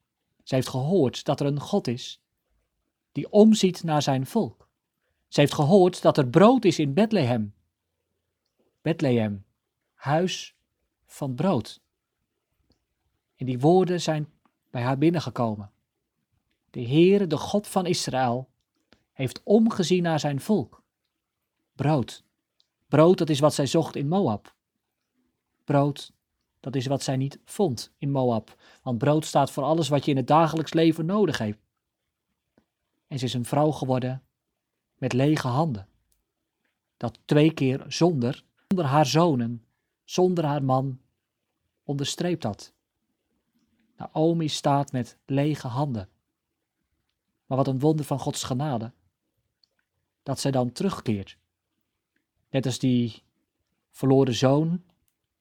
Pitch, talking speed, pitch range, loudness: 140 Hz, 125 wpm, 125-160 Hz, -24 LUFS